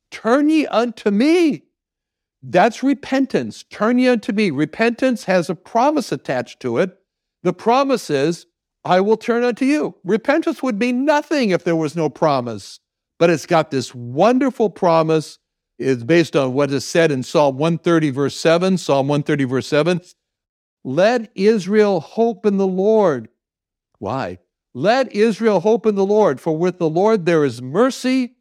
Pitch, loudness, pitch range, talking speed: 185 Hz, -18 LUFS, 150-230 Hz, 160 wpm